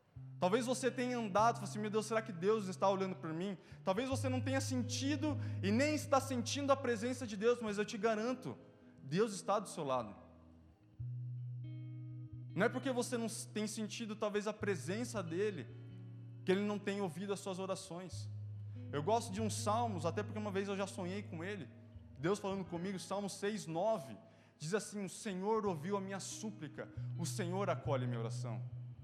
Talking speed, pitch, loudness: 190 wpm, 170 Hz, -39 LUFS